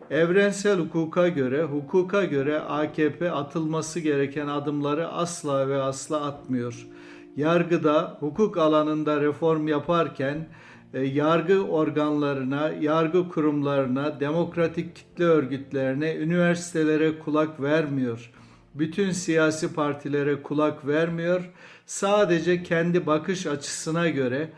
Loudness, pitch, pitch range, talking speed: -25 LUFS, 155 Hz, 145-170 Hz, 95 wpm